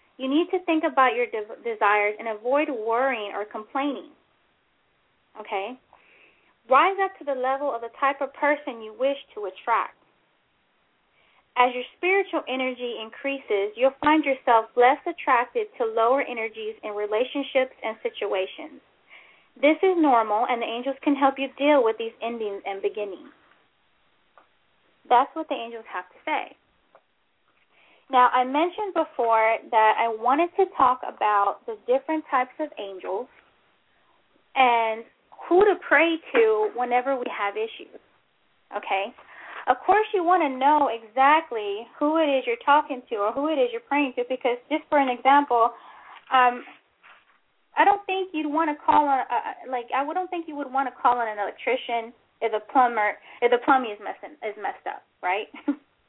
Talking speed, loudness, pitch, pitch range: 160 wpm, -24 LUFS, 265 Hz, 230-305 Hz